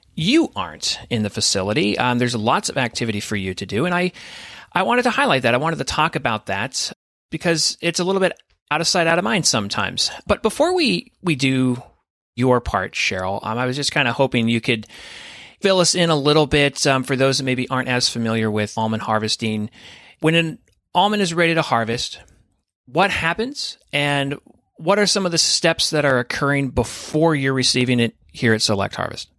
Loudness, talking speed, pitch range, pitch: -19 LUFS, 205 wpm, 115-165 Hz, 135 Hz